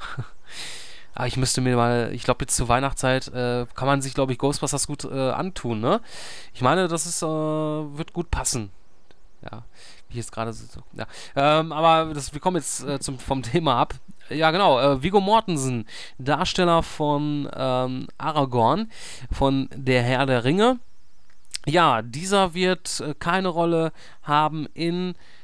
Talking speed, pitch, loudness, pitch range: 160 wpm, 140 Hz, -23 LUFS, 130-165 Hz